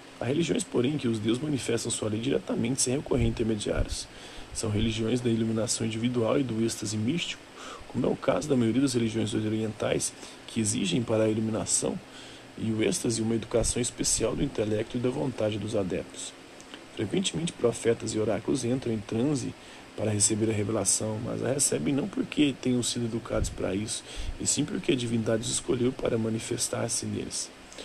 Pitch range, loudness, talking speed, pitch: 110-120 Hz, -28 LUFS, 175 wpm, 115 Hz